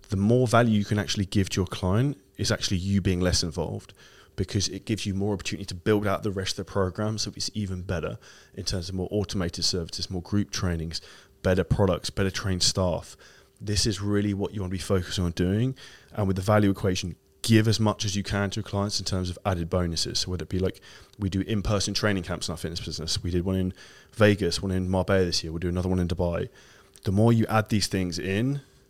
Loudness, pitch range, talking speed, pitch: -26 LUFS, 90-105 Hz, 240 wpm, 95 Hz